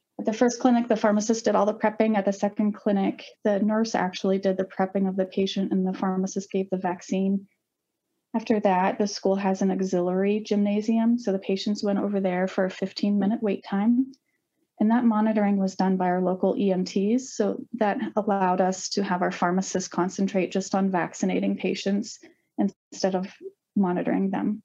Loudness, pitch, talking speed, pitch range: -25 LUFS, 200 Hz, 185 wpm, 190-220 Hz